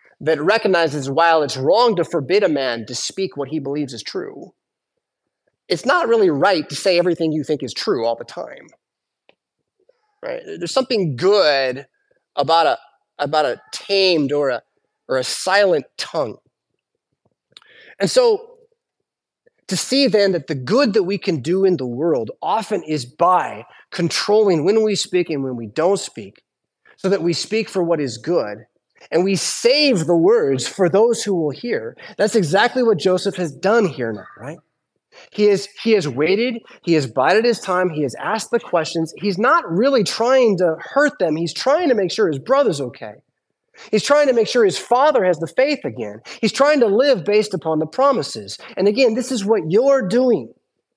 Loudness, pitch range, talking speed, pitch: -18 LUFS, 160-255 Hz, 180 wpm, 195 Hz